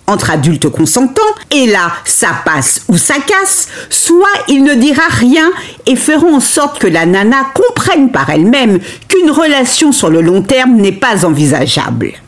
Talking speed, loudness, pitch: 165 wpm, -8 LUFS, 265 Hz